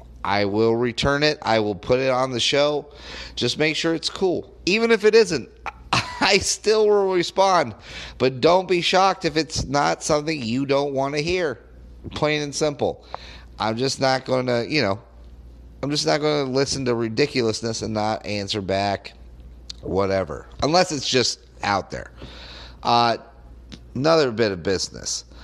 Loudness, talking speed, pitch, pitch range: -21 LUFS, 165 wpm, 125 Hz, 100-150 Hz